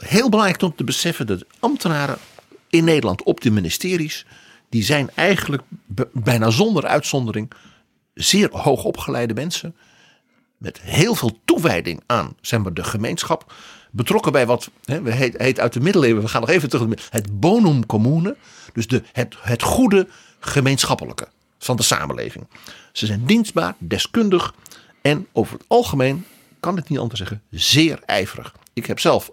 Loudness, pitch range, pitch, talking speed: -19 LUFS, 115-180 Hz, 140 Hz, 155 wpm